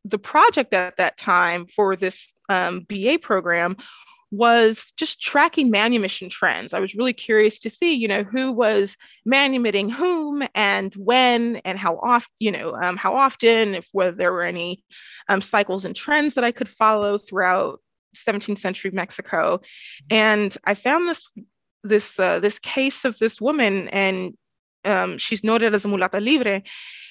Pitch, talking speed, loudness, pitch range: 210 Hz, 160 wpm, -20 LUFS, 190-240 Hz